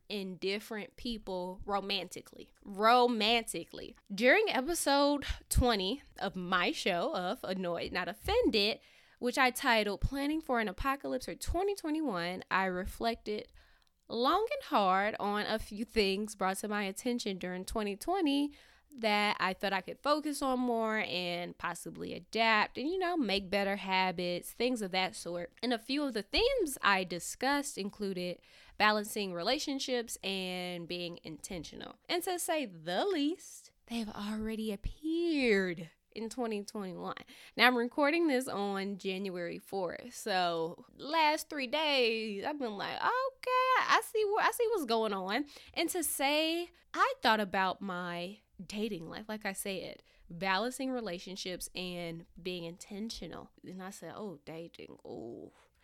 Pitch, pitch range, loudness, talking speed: 215 Hz, 190-270 Hz, -33 LUFS, 140 wpm